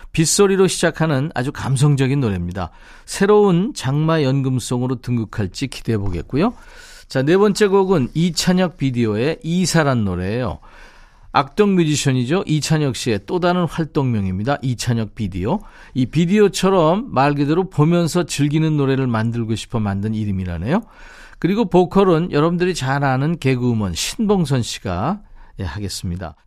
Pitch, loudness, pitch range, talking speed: 145 Hz, -18 LUFS, 115-175 Hz, 335 characters per minute